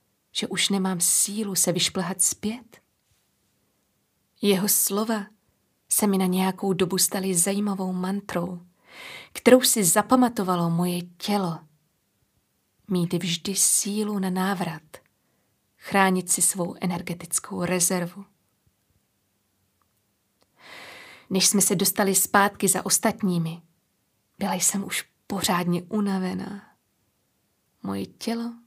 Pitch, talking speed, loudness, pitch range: 190 Hz, 95 wpm, -23 LUFS, 175-200 Hz